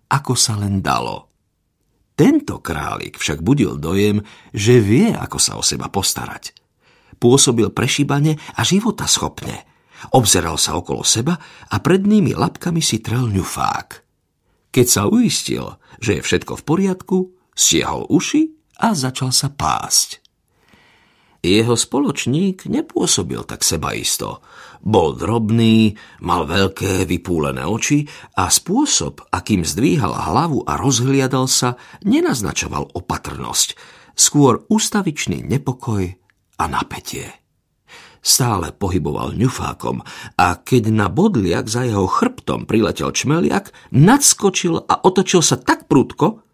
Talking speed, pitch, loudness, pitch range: 115 wpm, 130 Hz, -17 LUFS, 110-180 Hz